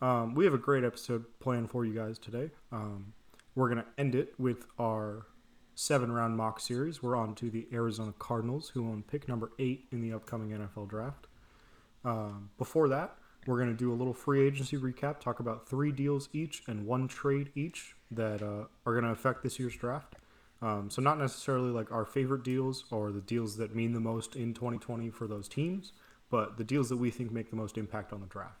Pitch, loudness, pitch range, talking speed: 120 Hz, -35 LUFS, 110-130 Hz, 215 wpm